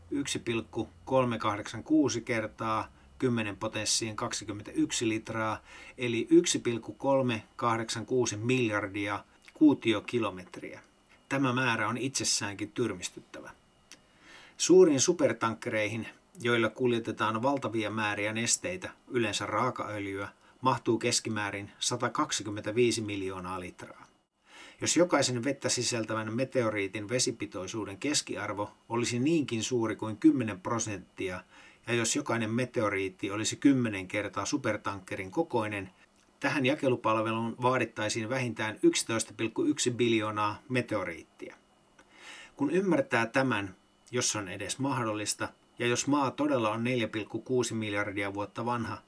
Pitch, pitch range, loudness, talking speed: 115 Hz, 105-125 Hz, -30 LUFS, 90 wpm